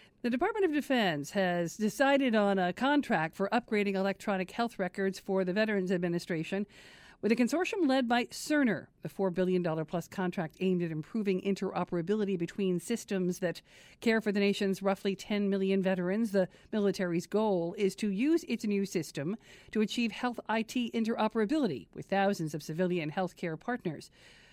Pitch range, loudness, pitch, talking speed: 180-225 Hz, -31 LUFS, 195 Hz, 160 wpm